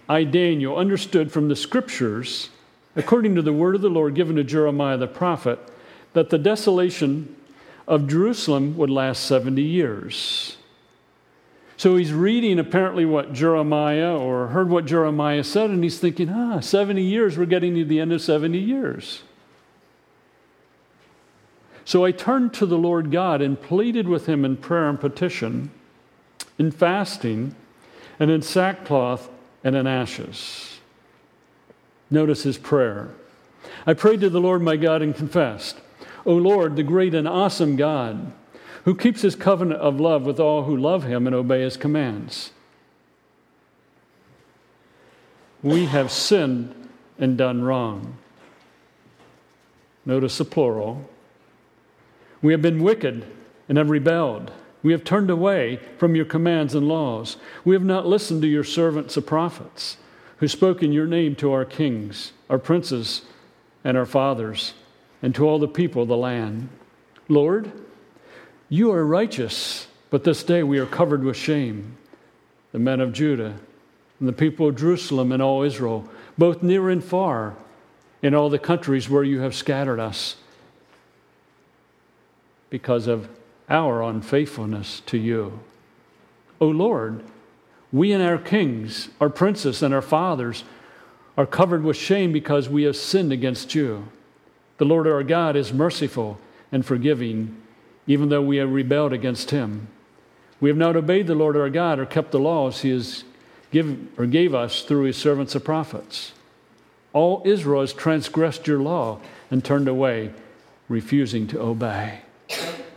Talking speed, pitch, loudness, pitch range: 150 wpm, 150 Hz, -21 LUFS, 130-170 Hz